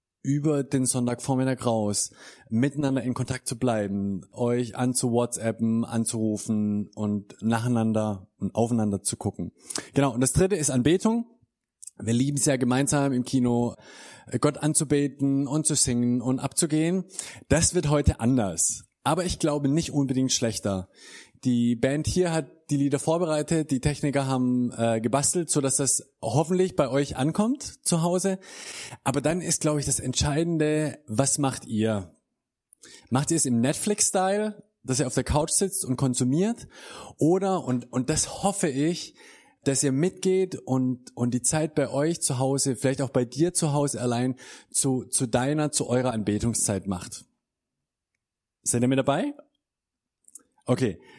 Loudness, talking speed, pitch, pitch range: -25 LUFS, 150 wpm, 135 Hz, 120-150 Hz